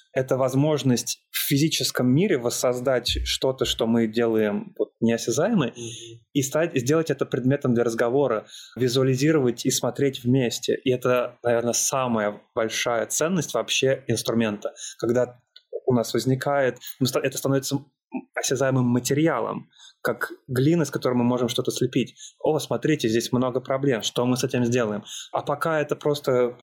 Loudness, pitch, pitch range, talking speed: -24 LUFS, 130 Hz, 120-140 Hz, 135 wpm